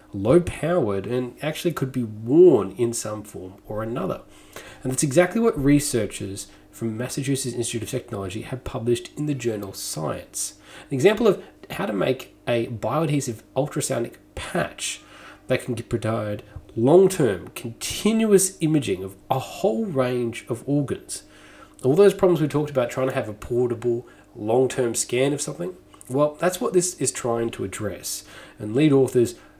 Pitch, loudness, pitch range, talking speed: 125 Hz, -23 LUFS, 115-150 Hz, 160 wpm